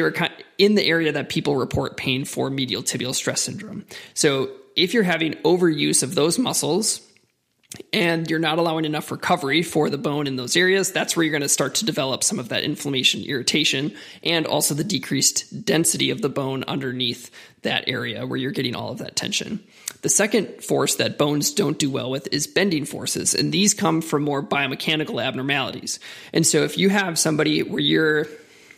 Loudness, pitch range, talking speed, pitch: -21 LUFS, 140-170 Hz, 190 wpm, 155 Hz